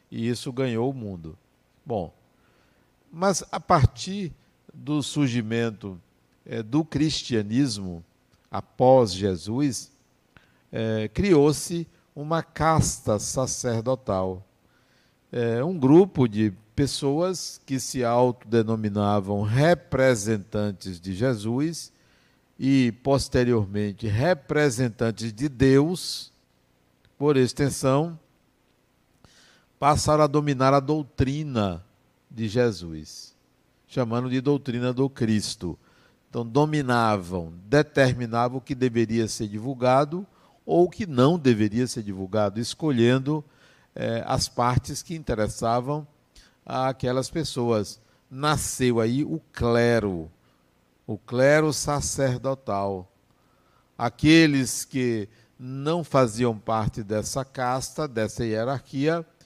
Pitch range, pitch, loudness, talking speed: 110-145 Hz, 125 Hz, -24 LUFS, 90 wpm